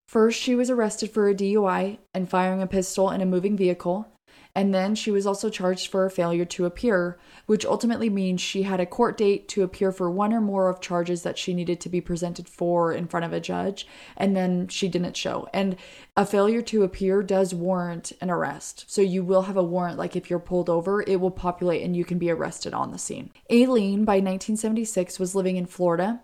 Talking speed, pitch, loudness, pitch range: 220 wpm, 190 Hz, -25 LUFS, 180-200 Hz